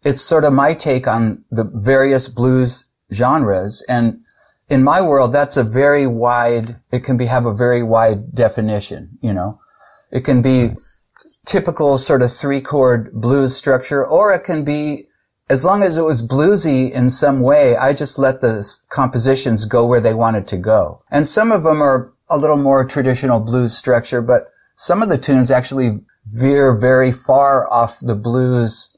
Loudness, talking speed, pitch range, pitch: -14 LUFS, 175 wpm, 120-140 Hz, 130 Hz